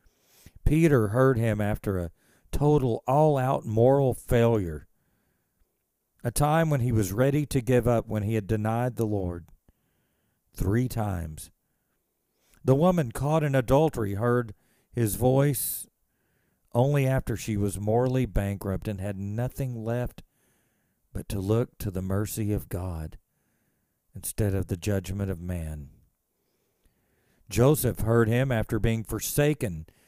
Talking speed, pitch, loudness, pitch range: 130 wpm, 115 Hz, -26 LUFS, 100-130 Hz